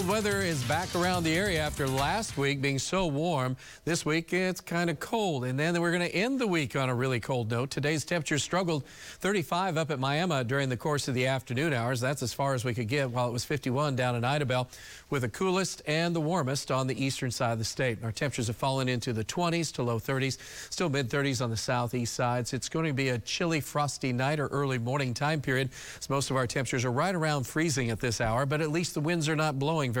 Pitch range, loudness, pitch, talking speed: 130-160 Hz, -29 LUFS, 140 Hz, 250 wpm